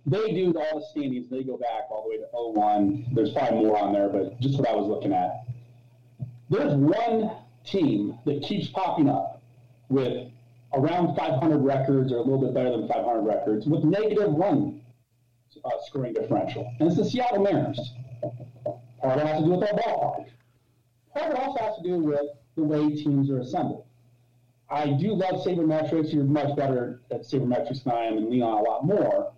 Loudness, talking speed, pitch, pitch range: -26 LUFS, 190 wpm, 135 Hz, 120-155 Hz